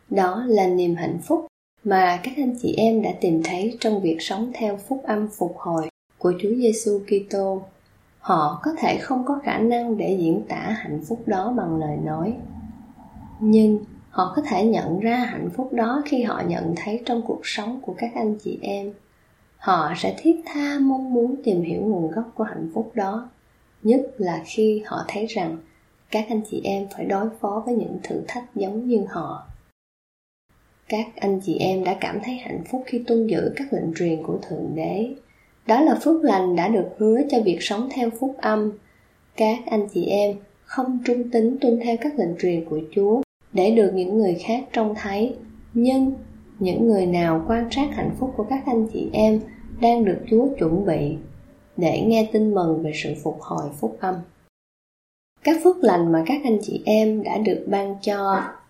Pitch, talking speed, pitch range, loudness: 215 Hz, 190 wpm, 185-240 Hz, -22 LUFS